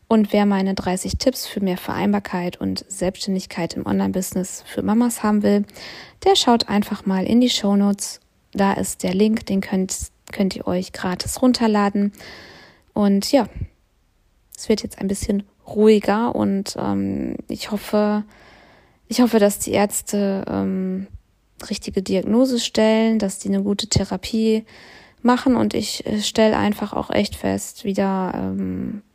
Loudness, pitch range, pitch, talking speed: -20 LUFS, 185-220 Hz, 205 Hz, 145 wpm